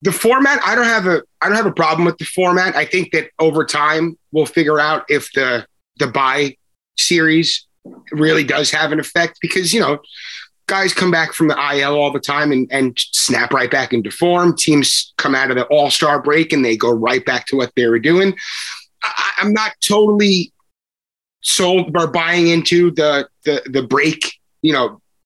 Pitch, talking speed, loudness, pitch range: 155 Hz, 195 wpm, -15 LUFS, 145-175 Hz